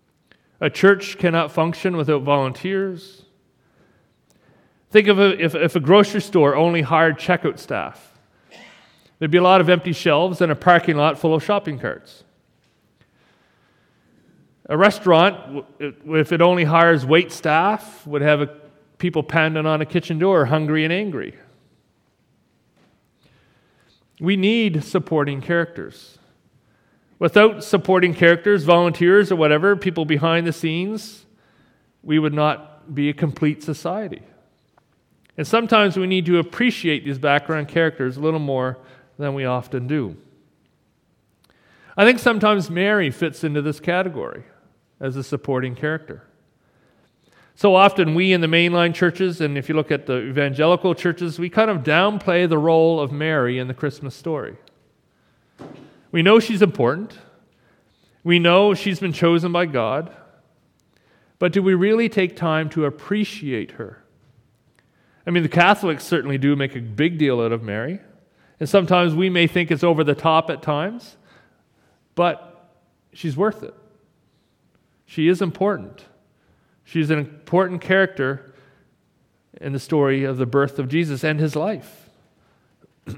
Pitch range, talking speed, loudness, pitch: 150-185 Hz, 140 wpm, -19 LUFS, 165 Hz